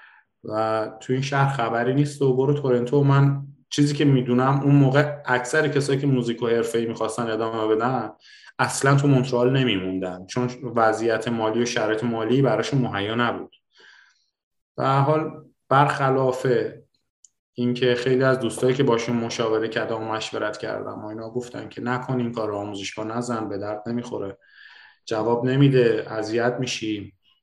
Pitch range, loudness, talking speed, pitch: 110-135 Hz, -22 LUFS, 150 wpm, 120 Hz